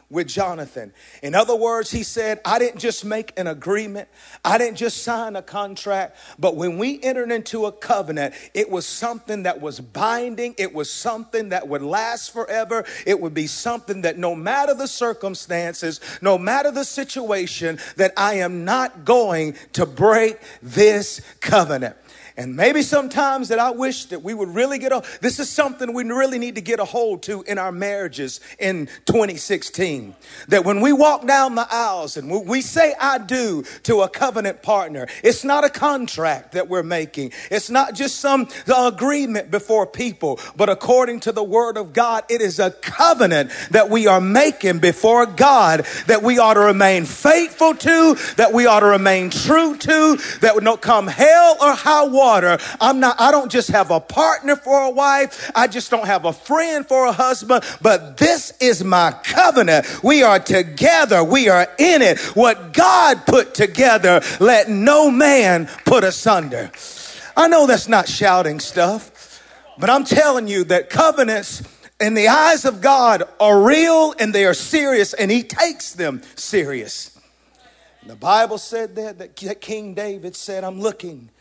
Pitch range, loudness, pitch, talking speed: 190-260 Hz, -16 LUFS, 220 Hz, 175 wpm